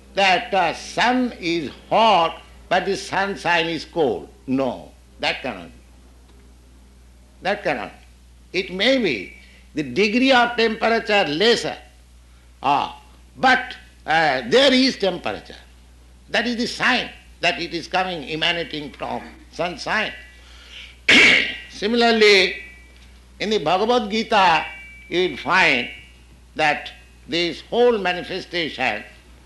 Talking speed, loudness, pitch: 110 wpm, -19 LUFS, 170 Hz